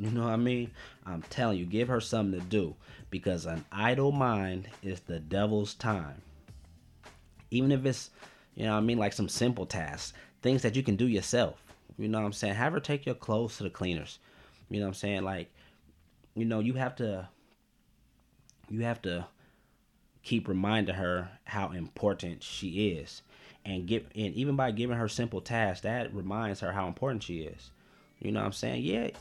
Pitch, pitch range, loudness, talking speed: 105 Hz, 95-115 Hz, -32 LUFS, 195 wpm